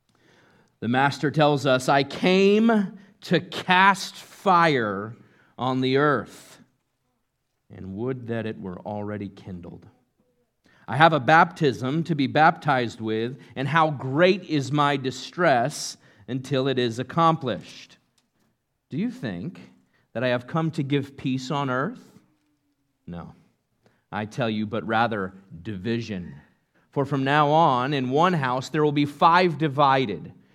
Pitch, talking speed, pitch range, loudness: 135 Hz, 135 wpm, 120-155 Hz, -23 LUFS